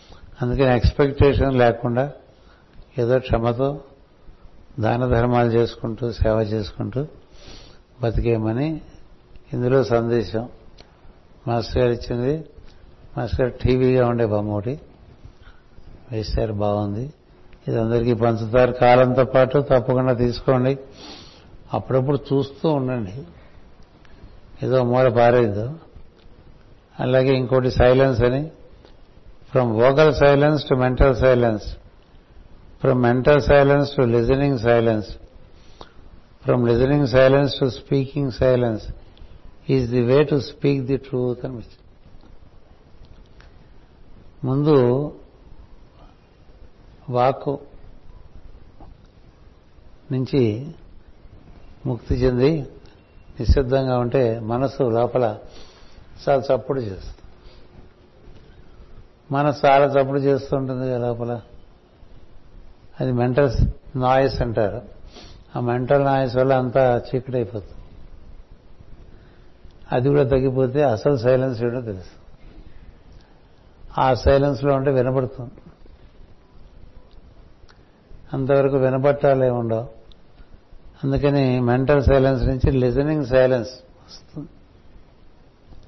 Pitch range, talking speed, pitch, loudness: 105-135 Hz, 80 wpm, 125 Hz, -20 LUFS